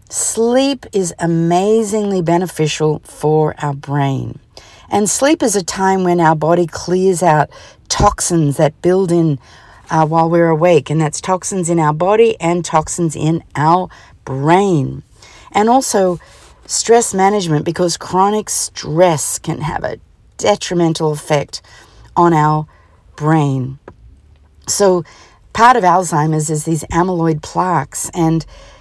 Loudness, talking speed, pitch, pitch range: -14 LUFS, 125 wpm, 165 Hz, 150-185 Hz